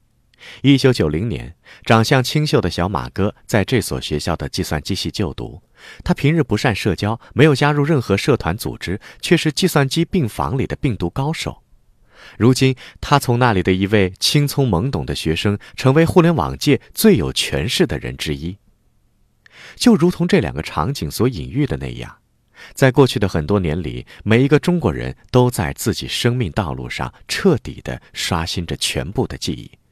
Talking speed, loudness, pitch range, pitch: 265 characters per minute, -18 LUFS, 85-140 Hz, 115 Hz